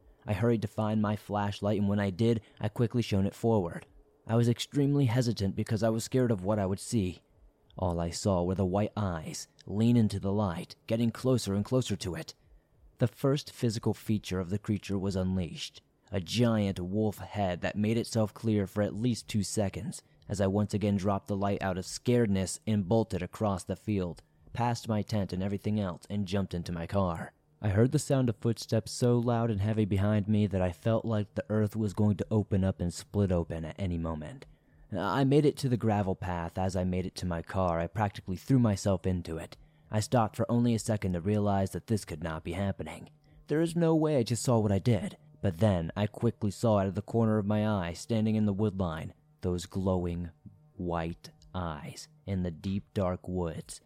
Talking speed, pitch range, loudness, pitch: 215 wpm, 95-115 Hz, -31 LUFS, 105 Hz